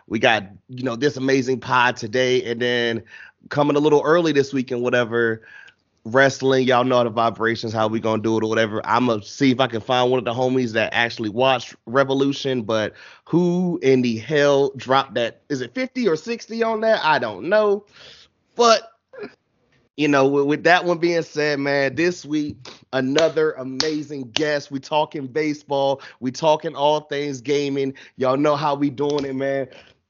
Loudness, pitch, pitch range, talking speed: -20 LUFS, 135 Hz, 125-150 Hz, 185 wpm